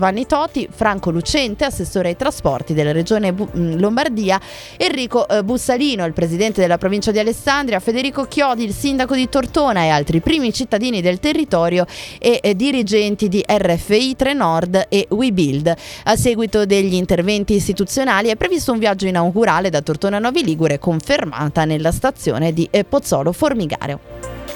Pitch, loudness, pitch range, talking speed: 205 Hz, -17 LUFS, 175-255 Hz, 140 wpm